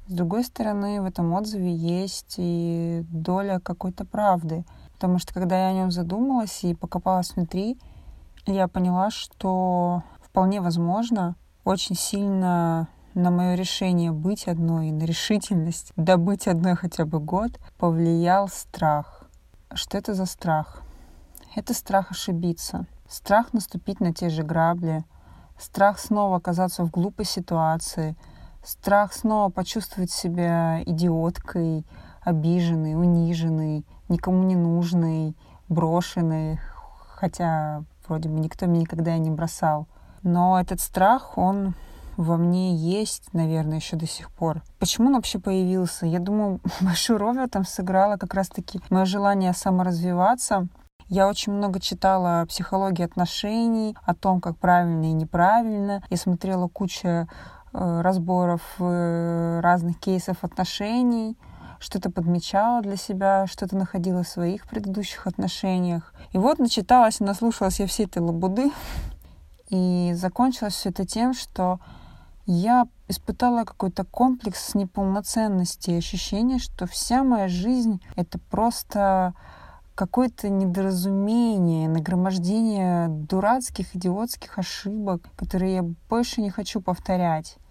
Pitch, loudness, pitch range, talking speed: 185 Hz, -24 LUFS, 170-200 Hz, 120 wpm